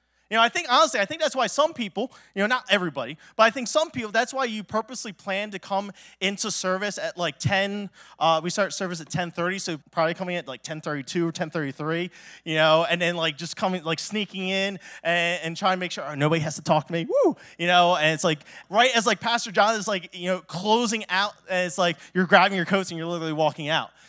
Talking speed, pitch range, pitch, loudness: 245 wpm, 165-210 Hz, 185 Hz, -24 LUFS